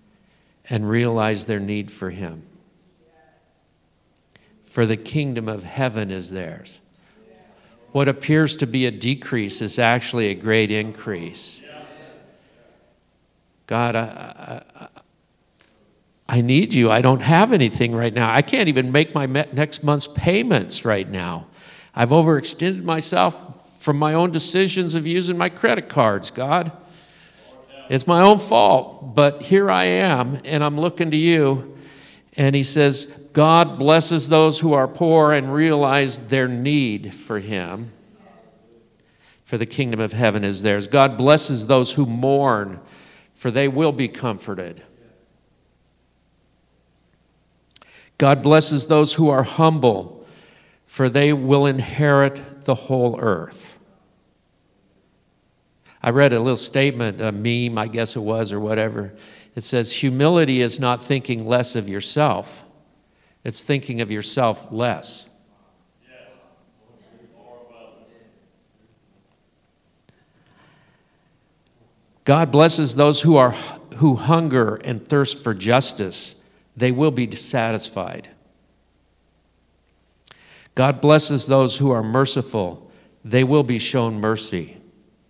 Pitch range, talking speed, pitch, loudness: 110-150 Hz, 120 wpm, 130 Hz, -19 LUFS